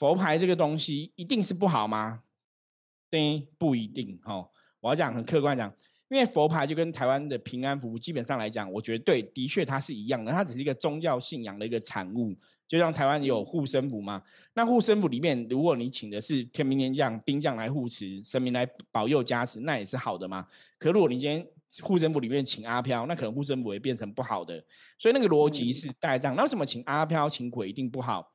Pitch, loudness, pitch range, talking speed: 135 Hz, -29 LUFS, 120-155 Hz, 330 characters per minute